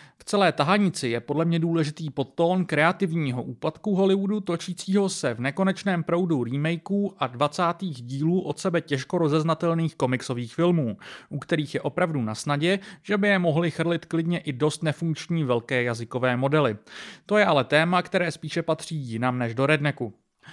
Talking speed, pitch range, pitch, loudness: 160 wpm, 140-180 Hz, 160 Hz, -25 LUFS